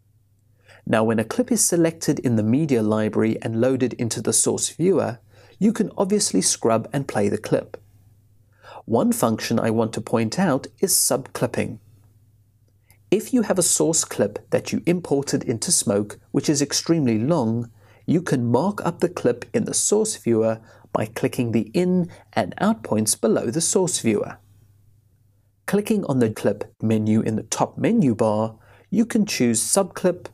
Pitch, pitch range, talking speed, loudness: 115 Hz, 110-160 Hz, 165 wpm, -21 LUFS